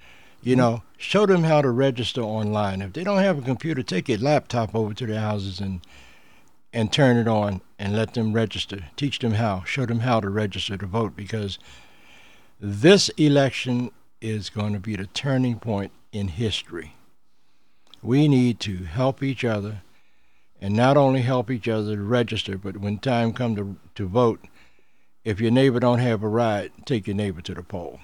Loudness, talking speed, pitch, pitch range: -23 LUFS, 185 wpm, 110 Hz, 100-125 Hz